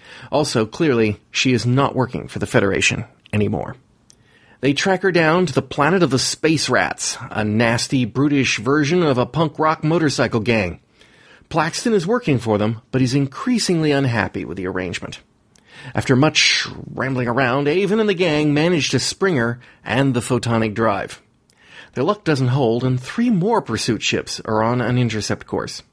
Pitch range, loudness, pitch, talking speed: 115-155 Hz, -19 LUFS, 130 Hz, 170 wpm